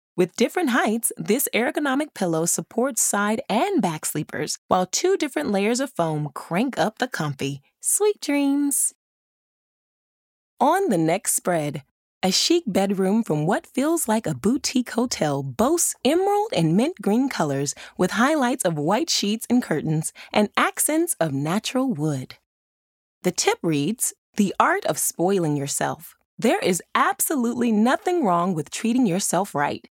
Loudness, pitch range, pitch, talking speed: -22 LUFS, 165-265 Hz, 210 Hz, 145 wpm